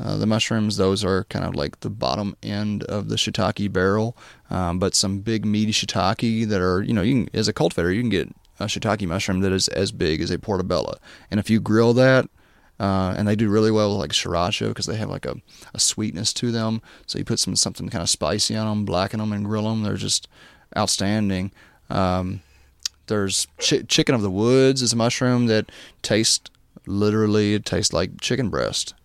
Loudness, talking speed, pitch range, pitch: -22 LUFS, 210 wpm, 95-110 Hz, 105 Hz